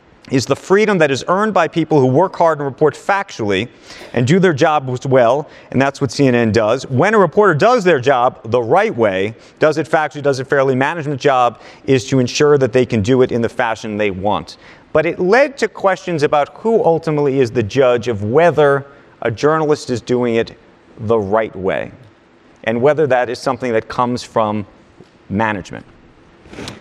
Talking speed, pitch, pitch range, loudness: 190 wpm, 135 Hz, 120-160 Hz, -15 LUFS